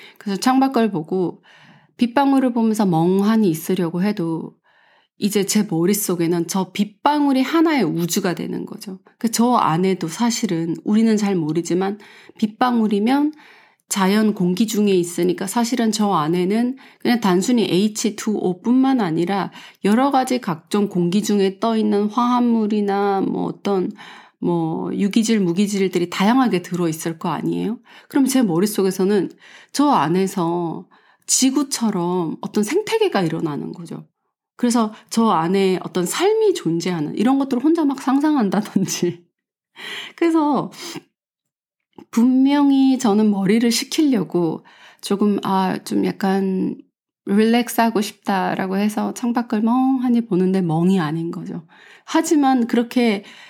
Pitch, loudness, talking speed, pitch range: 210 Hz, -19 LUFS, 280 characters per minute, 185-245 Hz